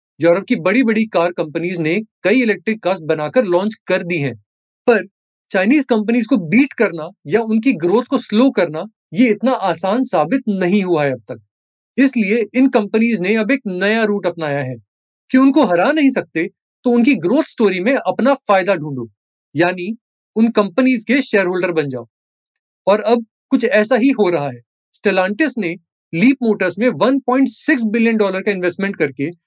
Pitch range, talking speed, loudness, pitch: 175-245 Hz, 110 wpm, -16 LUFS, 210 Hz